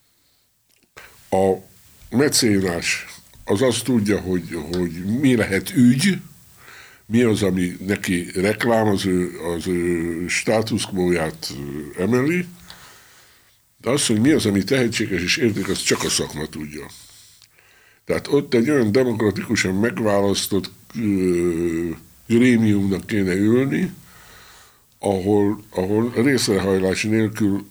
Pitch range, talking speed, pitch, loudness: 90-115 Hz, 100 wpm, 100 Hz, -20 LUFS